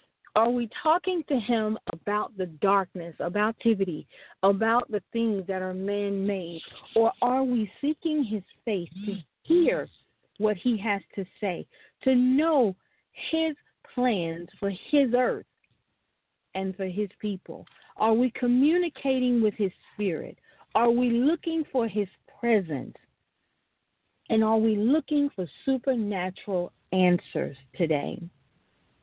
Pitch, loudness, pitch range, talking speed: 220 Hz, -27 LUFS, 195-255 Hz, 125 wpm